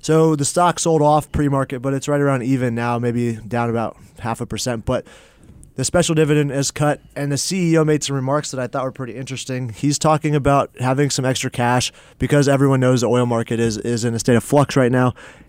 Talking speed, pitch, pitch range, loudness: 225 wpm, 135 Hz, 120-145 Hz, -19 LUFS